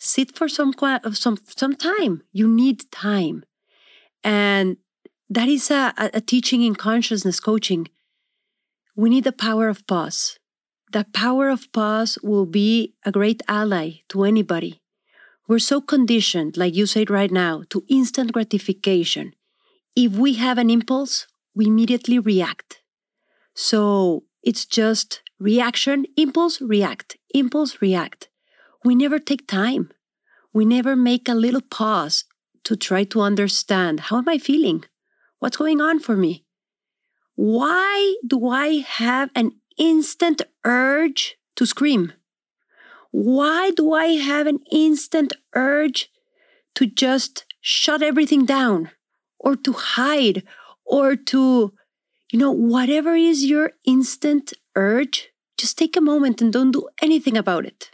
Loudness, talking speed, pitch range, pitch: -19 LUFS, 135 wpm, 210-290 Hz, 245 Hz